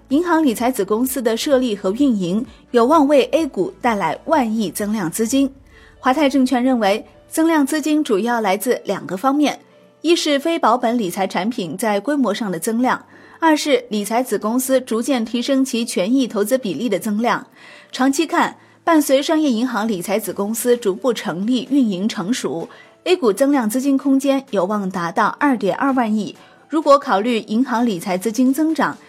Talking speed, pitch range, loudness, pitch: 270 characters per minute, 215-275 Hz, -18 LUFS, 245 Hz